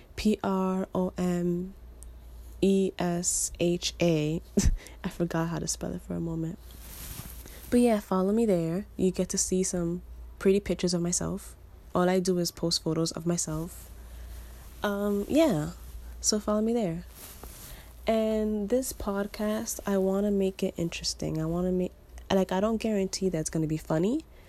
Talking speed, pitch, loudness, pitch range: 145 wpm, 185 Hz, -29 LUFS, 170-200 Hz